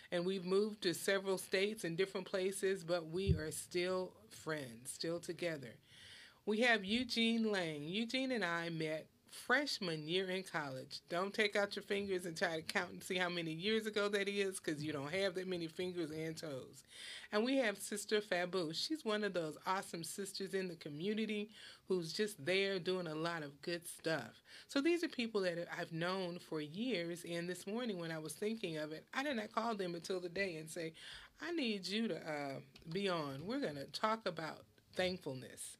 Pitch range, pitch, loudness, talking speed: 165-205 Hz, 185 Hz, -40 LUFS, 200 wpm